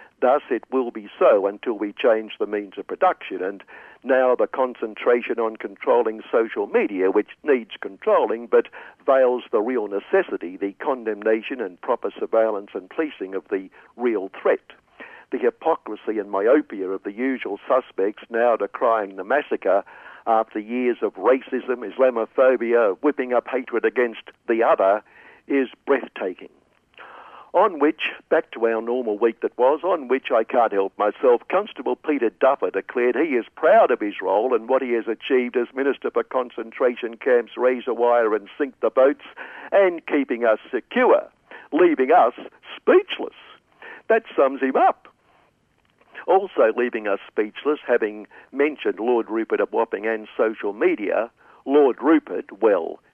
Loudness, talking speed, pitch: -22 LUFS, 150 wpm, 130 Hz